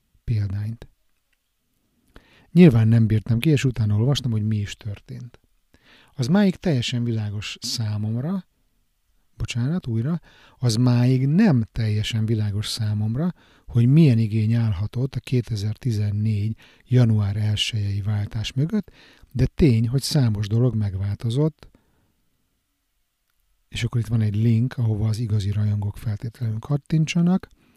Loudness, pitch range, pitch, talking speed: -22 LUFS, 105-130 Hz, 115 Hz, 115 wpm